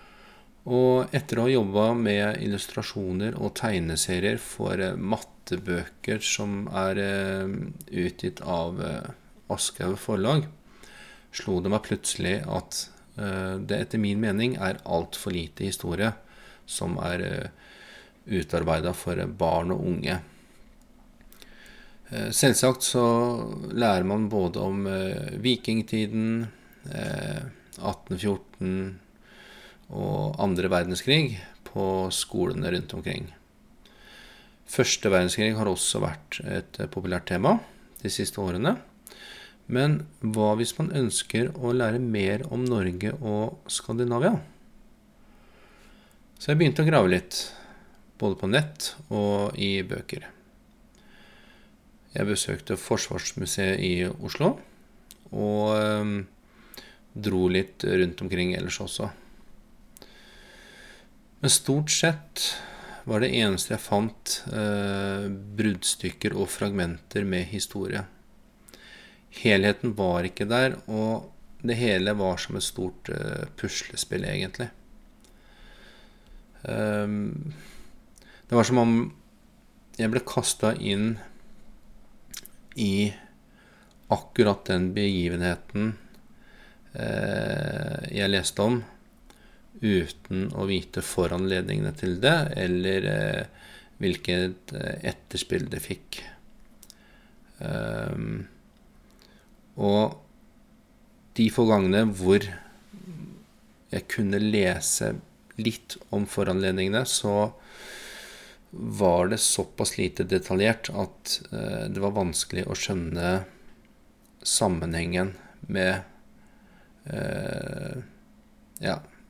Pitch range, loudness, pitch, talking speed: 95-125 Hz, -27 LUFS, 105 Hz, 95 wpm